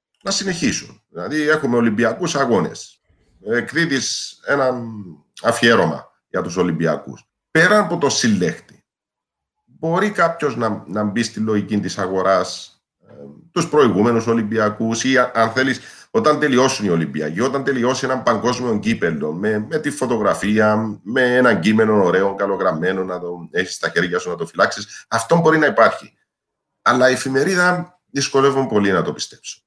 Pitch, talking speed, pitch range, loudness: 125 Hz, 140 wpm, 105-155 Hz, -18 LUFS